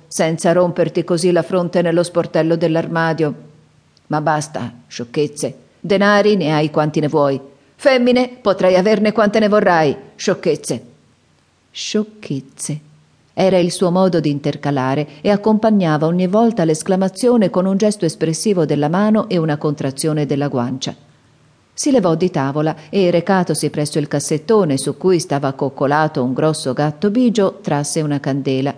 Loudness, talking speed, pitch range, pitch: -16 LUFS, 140 wpm, 145-190 Hz, 160 Hz